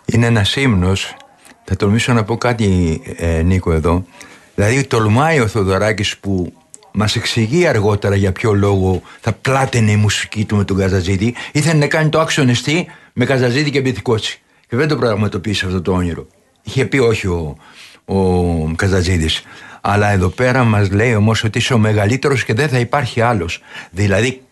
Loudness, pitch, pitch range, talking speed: -15 LUFS, 105 Hz, 95-125 Hz, 165 wpm